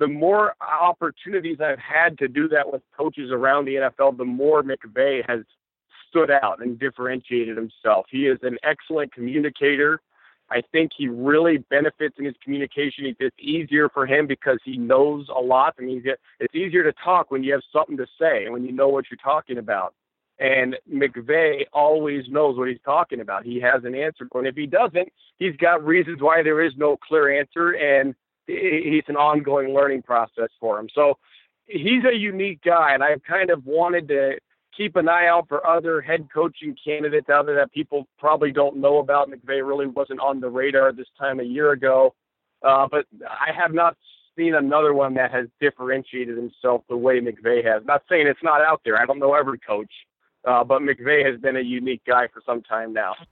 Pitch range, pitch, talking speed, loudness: 130-160 Hz, 140 Hz, 195 wpm, -21 LUFS